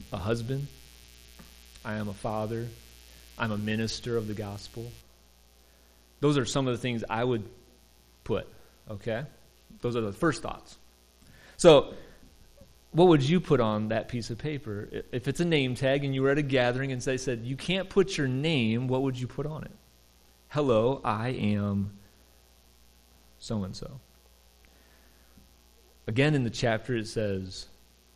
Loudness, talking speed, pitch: -28 LUFS, 160 wpm, 110 Hz